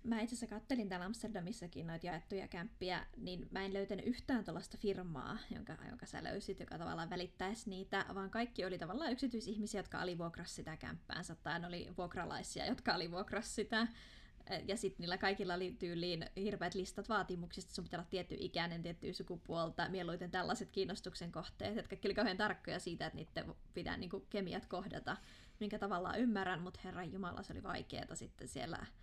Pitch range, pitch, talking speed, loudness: 175-210 Hz, 190 Hz, 165 wpm, -43 LUFS